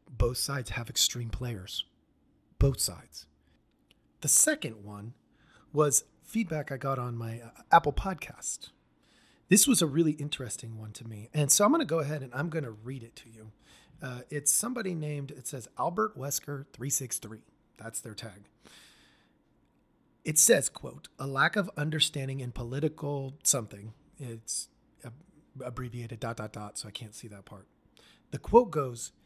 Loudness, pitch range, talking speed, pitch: -29 LUFS, 115-150 Hz, 160 wpm, 130 Hz